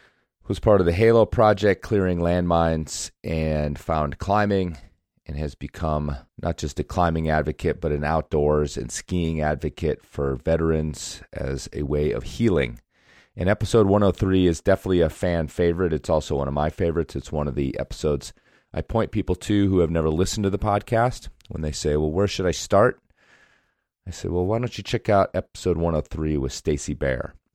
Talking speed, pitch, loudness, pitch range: 180 wpm, 80 Hz, -23 LUFS, 75-95 Hz